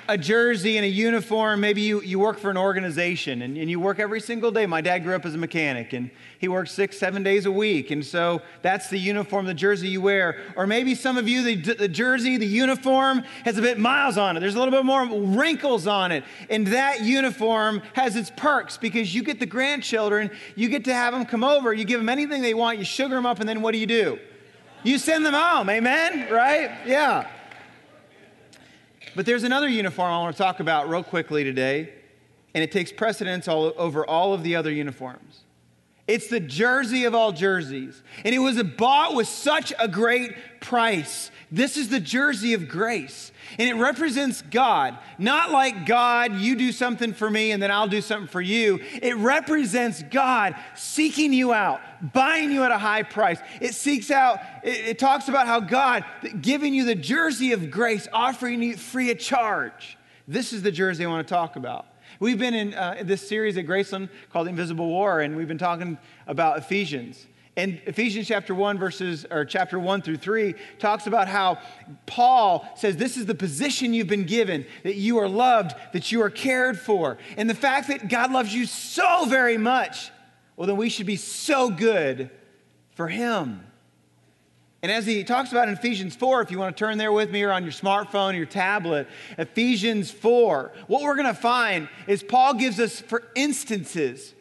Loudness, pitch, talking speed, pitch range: -23 LUFS, 220 Hz, 200 wpm, 185-250 Hz